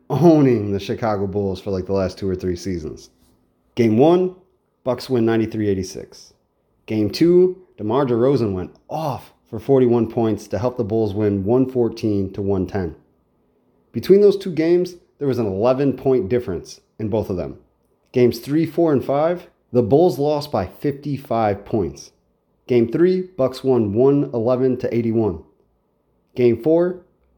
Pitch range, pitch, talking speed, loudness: 105-145 Hz, 120 Hz, 160 wpm, -19 LUFS